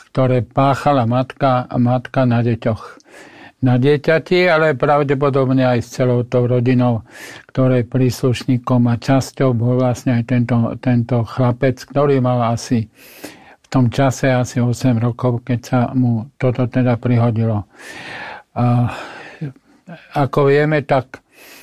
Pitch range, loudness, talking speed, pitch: 120-135 Hz, -16 LUFS, 125 wpm, 125 Hz